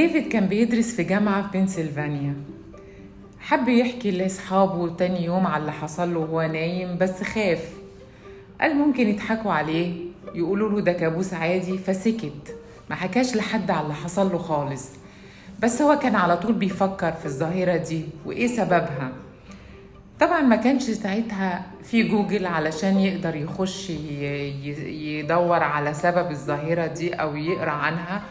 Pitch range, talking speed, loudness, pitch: 155-205 Hz, 140 wpm, -24 LUFS, 175 Hz